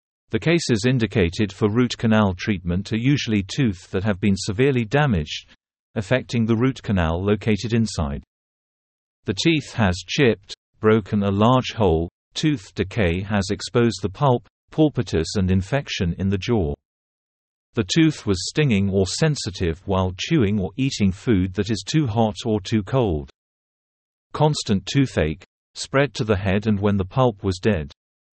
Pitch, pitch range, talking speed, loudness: 110 Hz, 95-125 Hz, 150 wpm, -21 LUFS